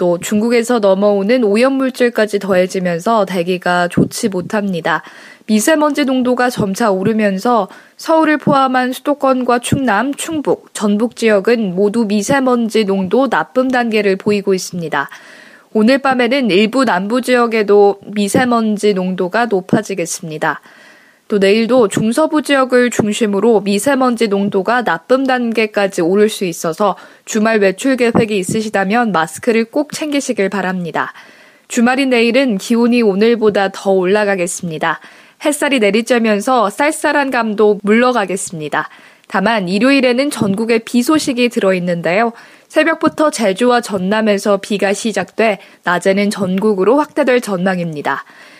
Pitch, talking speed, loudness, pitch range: 220 Hz, 320 characters per minute, -14 LUFS, 195-250 Hz